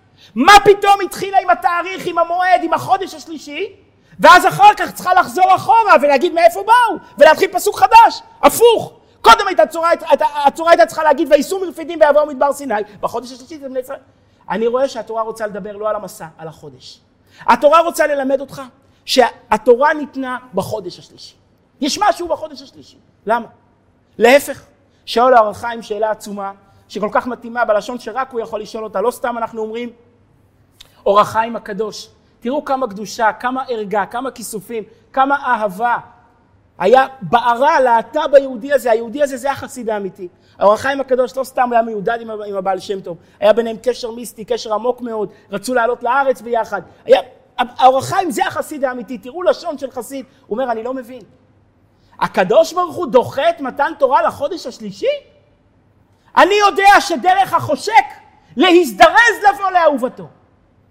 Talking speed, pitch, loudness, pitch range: 155 wpm, 260 Hz, -14 LUFS, 220-330 Hz